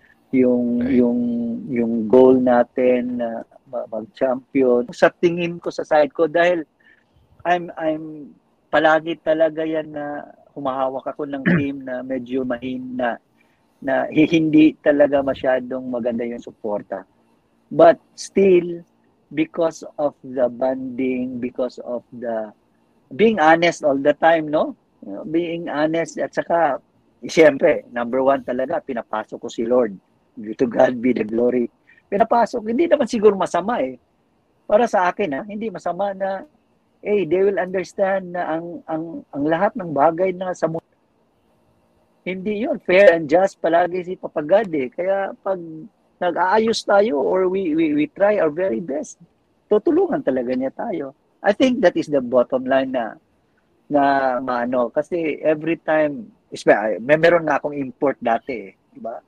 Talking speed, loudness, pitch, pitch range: 145 wpm, -20 LUFS, 155 Hz, 130-185 Hz